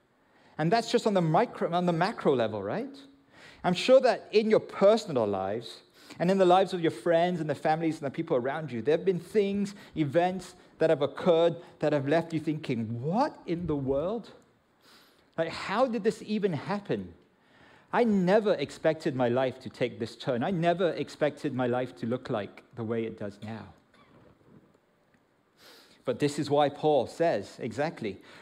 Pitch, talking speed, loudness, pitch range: 165 Hz, 180 wpm, -28 LUFS, 135-190 Hz